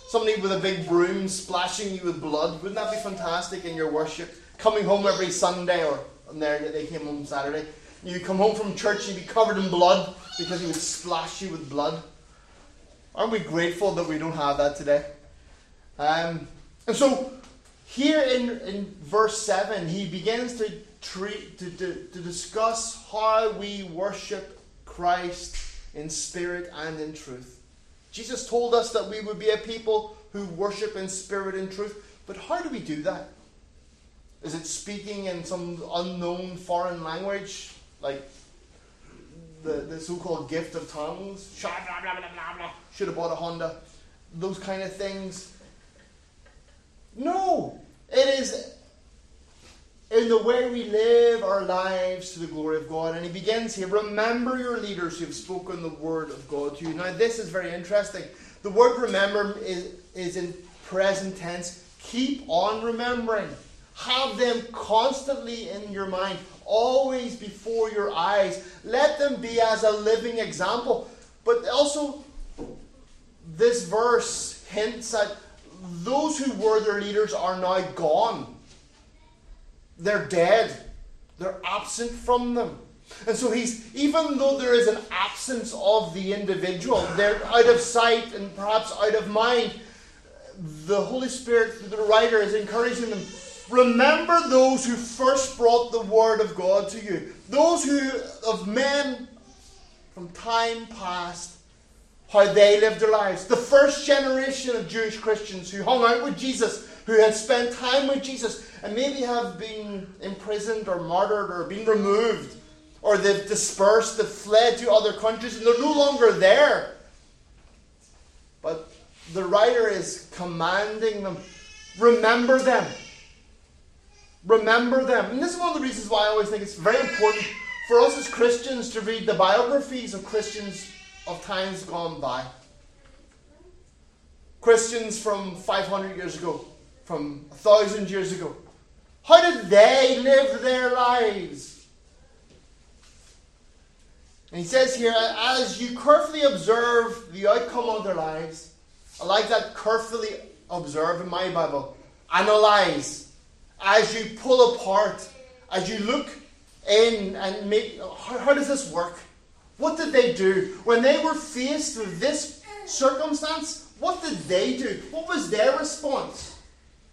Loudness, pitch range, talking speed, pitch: -24 LUFS, 170-235 Hz, 150 wpm, 205 Hz